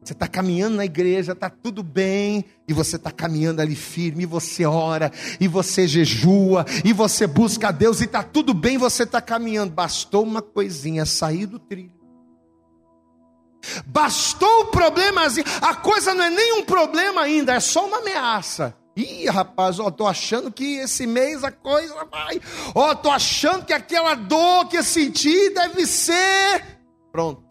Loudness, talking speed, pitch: -20 LUFS, 165 wpm, 215 Hz